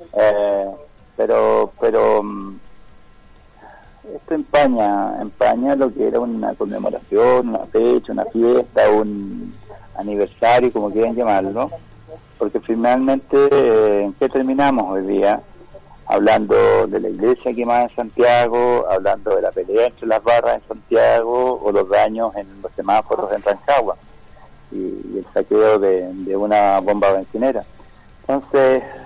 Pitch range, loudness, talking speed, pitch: 105-140 Hz, -17 LUFS, 130 wpm, 120 Hz